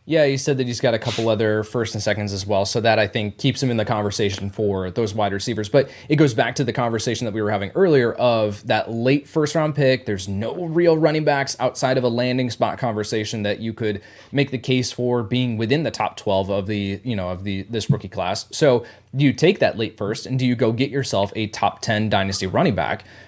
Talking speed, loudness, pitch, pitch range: 245 wpm, -21 LUFS, 115 Hz, 105-130 Hz